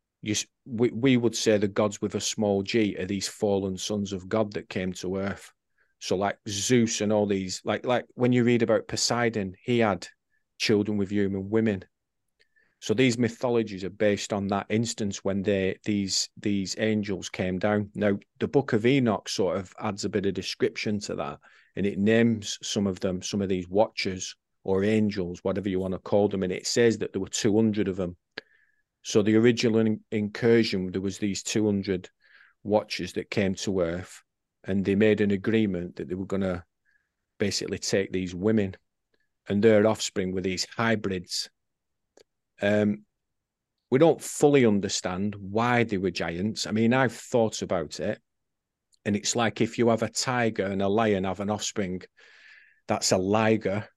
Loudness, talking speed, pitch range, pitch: -26 LUFS, 180 wpm, 95-110 Hz, 105 Hz